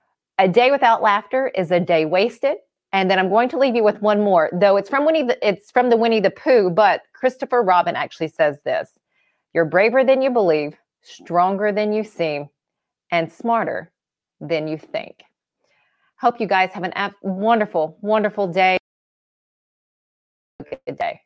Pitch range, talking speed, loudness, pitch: 180-235 Hz, 170 wpm, -19 LUFS, 205 Hz